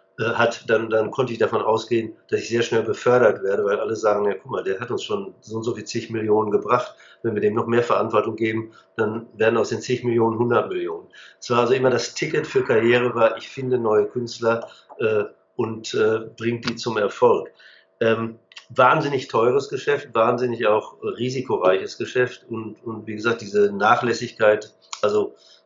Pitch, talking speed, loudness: 120 Hz, 185 wpm, -22 LUFS